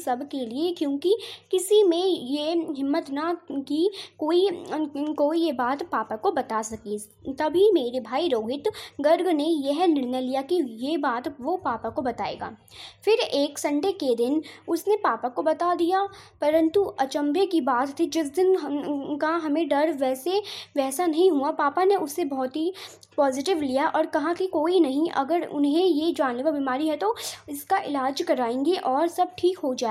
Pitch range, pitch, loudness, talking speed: 280-355 Hz, 315 Hz, -25 LUFS, 170 wpm